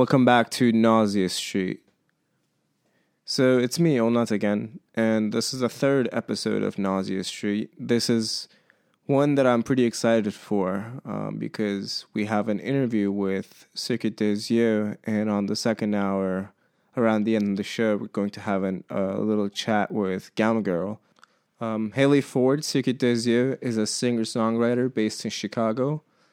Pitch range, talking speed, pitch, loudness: 105-125 Hz, 155 wpm, 110 Hz, -24 LUFS